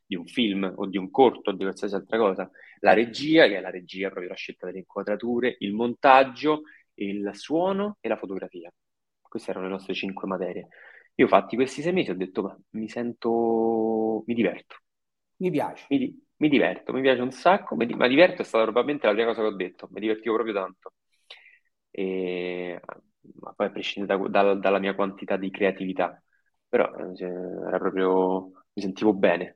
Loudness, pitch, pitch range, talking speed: -25 LUFS, 100 Hz, 95-120 Hz, 185 wpm